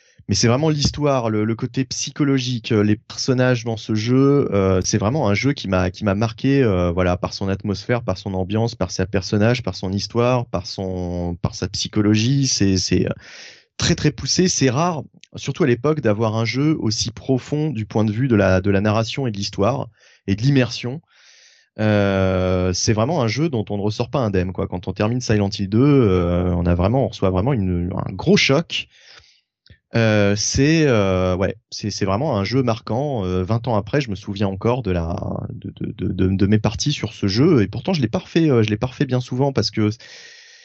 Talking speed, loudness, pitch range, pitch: 210 wpm, -20 LUFS, 100-130 Hz, 110 Hz